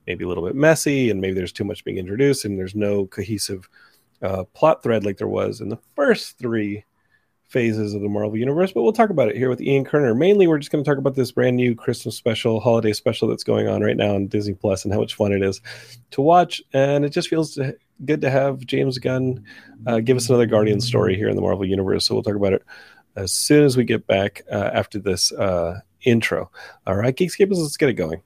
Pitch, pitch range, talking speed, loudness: 120 Hz, 105-140 Hz, 240 wpm, -20 LUFS